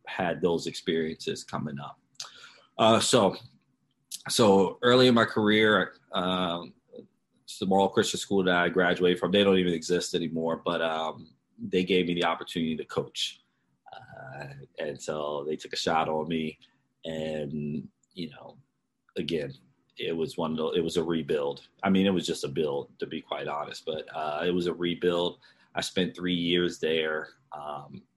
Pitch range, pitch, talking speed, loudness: 80-90 Hz, 85 Hz, 170 wpm, -27 LUFS